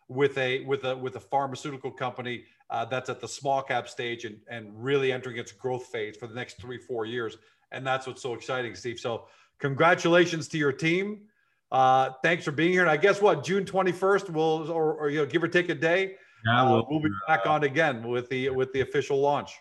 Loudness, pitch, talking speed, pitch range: -27 LUFS, 140 Hz, 220 wpm, 125-160 Hz